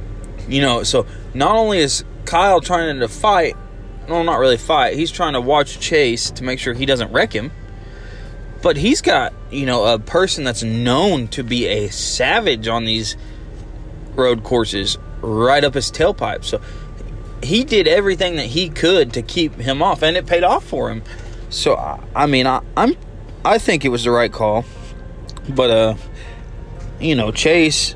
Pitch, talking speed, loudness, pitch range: 120 Hz, 165 wpm, -17 LUFS, 110-155 Hz